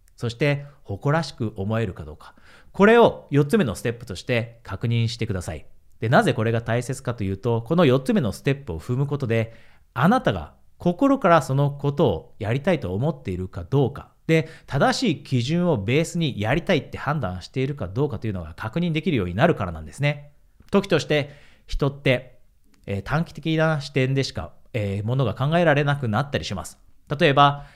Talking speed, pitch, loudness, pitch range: 385 characters per minute, 130 Hz, -23 LUFS, 110-155 Hz